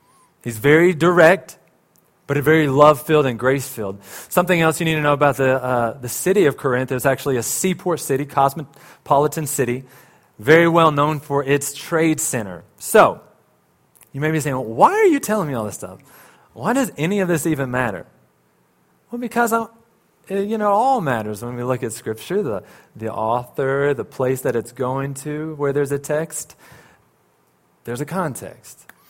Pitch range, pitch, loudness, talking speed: 125-160 Hz, 140 Hz, -19 LUFS, 175 wpm